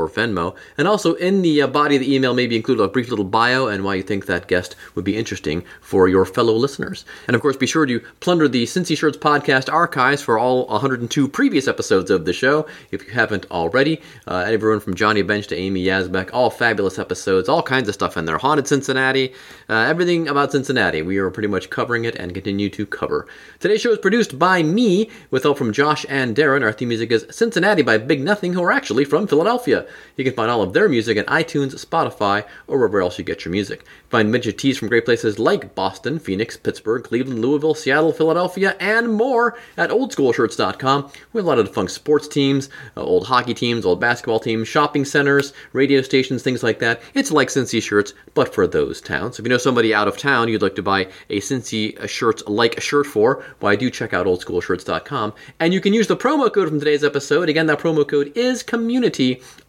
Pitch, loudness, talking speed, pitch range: 135 Hz, -19 LUFS, 215 wpm, 110-160 Hz